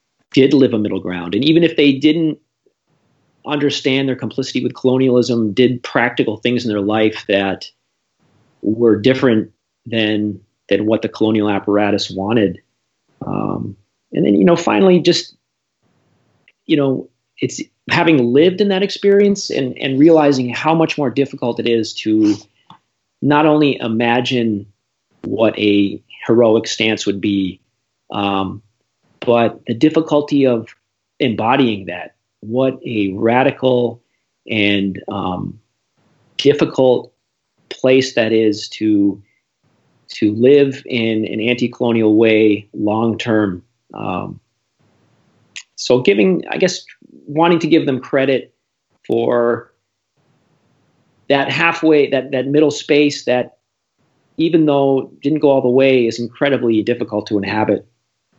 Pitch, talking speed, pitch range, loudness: 120 Hz, 125 wpm, 110-140 Hz, -15 LUFS